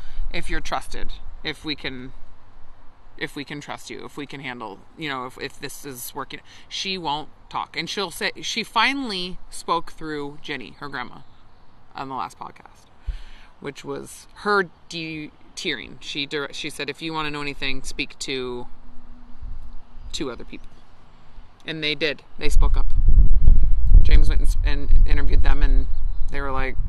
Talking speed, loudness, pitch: 165 wpm, -26 LUFS, 130 Hz